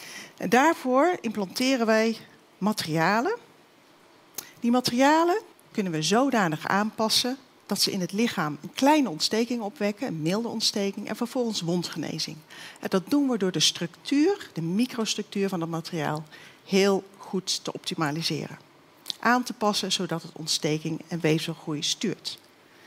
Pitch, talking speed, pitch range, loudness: 200 Hz, 135 wpm, 165-240 Hz, -26 LUFS